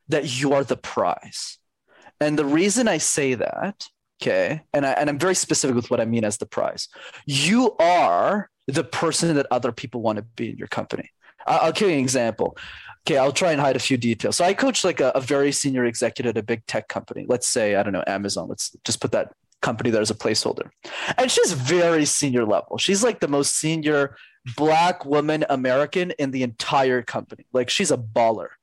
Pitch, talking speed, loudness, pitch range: 140 Hz, 215 wpm, -22 LUFS, 125-165 Hz